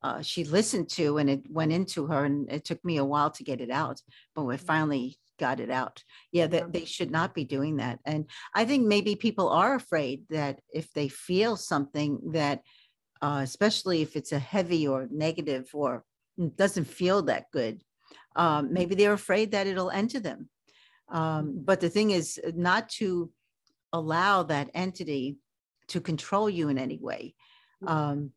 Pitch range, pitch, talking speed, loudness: 145-190 Hz, 165 Hz, 180 wpm, -29 LUFS